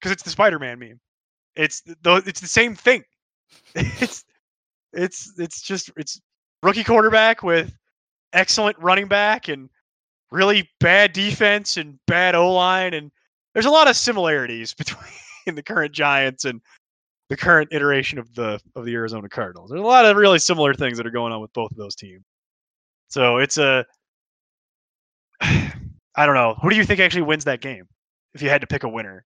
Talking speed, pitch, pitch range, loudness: 180 wpm, 155 Hz, 125-195 Hz, -18 LUFS